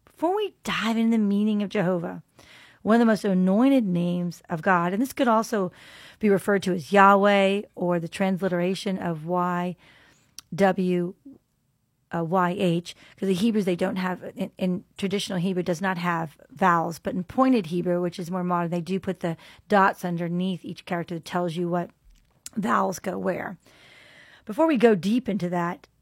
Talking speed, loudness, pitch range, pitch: 170 wpm, -24 LUFS, 175-205 Hz, 185 Hz